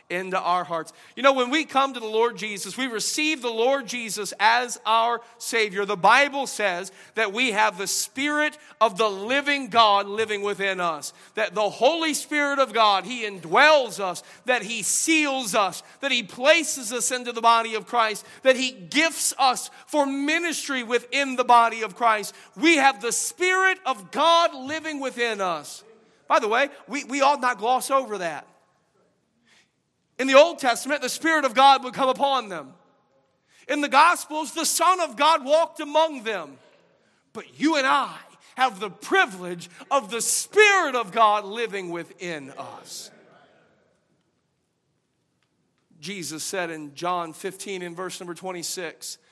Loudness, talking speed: -22 LUFS, 160 wpm